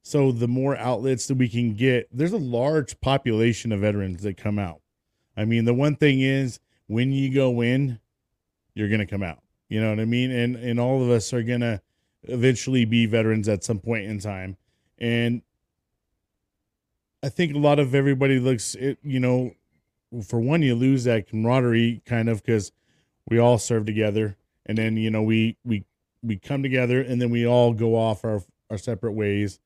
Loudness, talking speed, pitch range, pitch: -23 LUFS, 195 wpm, 110-130 Hz, 120 Hz